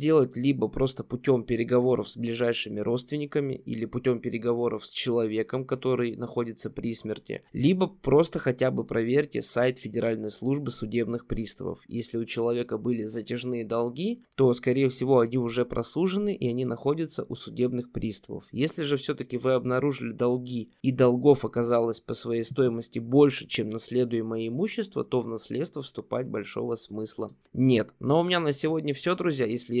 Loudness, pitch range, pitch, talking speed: -28 LUFS, 115-135 Hz, 125 Hz, 150 wpm